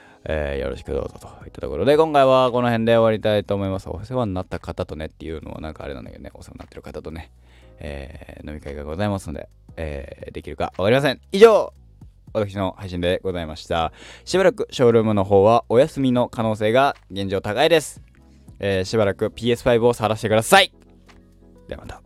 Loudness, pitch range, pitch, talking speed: -20 LUFS, 80-115 Hz, 100 Hz, 425 characters per minute